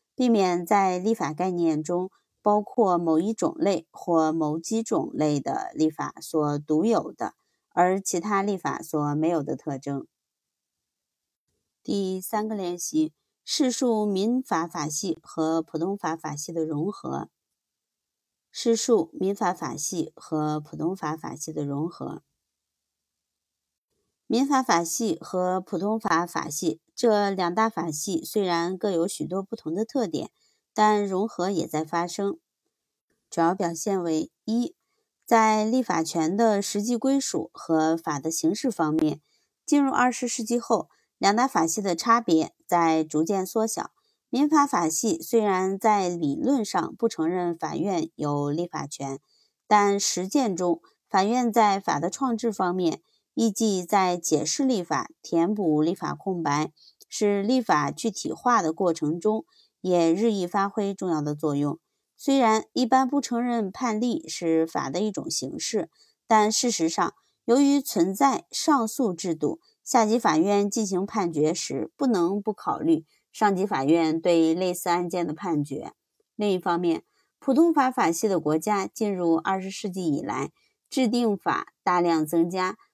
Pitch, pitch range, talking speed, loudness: 185 Hz, 165-225 Hz, 210 characters per minute, -25 LUFS